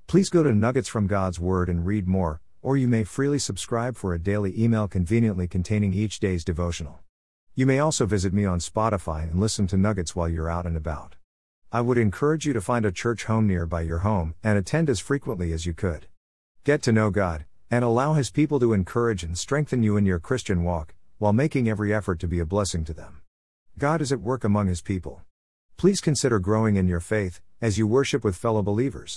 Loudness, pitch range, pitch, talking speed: -24 LUFS, 85-115 Hz, 105 Hz, 220 wpm